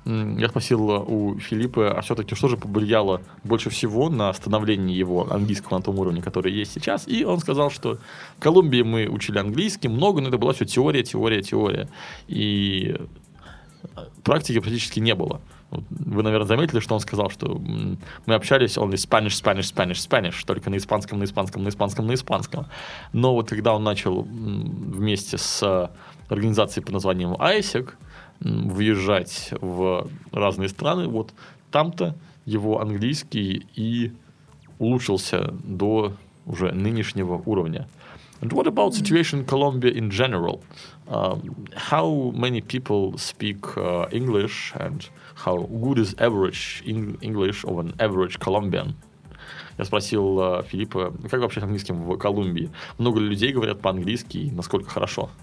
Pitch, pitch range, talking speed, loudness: 105 Hz, 95-115 Hz, 145 wpm, -24 LUFS